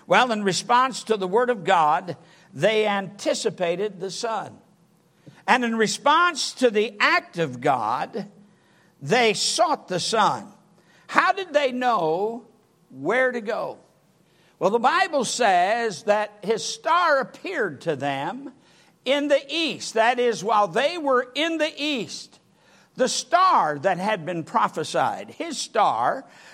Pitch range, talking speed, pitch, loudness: 195-275 Hz, 135 wpm, 225 Hz, -22 LUFS